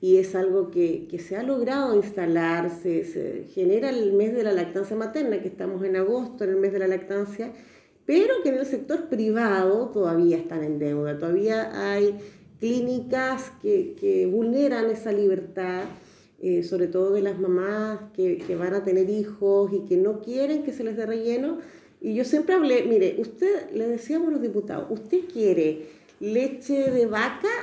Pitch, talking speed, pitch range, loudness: 215 Hz, 180 wpm, 190-260 Hz, -25 LUFS